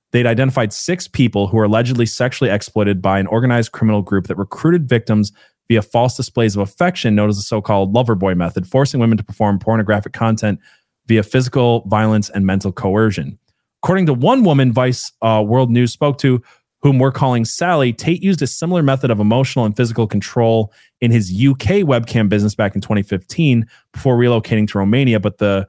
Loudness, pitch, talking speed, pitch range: -16 LUFS, 115 Hz, 185 wpm, 105-130 Hz